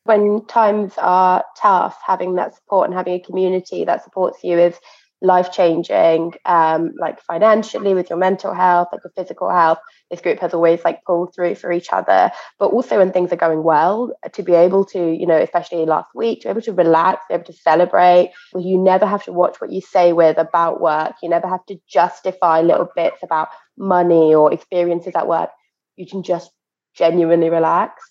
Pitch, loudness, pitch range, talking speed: 180 Hz, -16 LUFS, 170-185 Hz, 195 wpm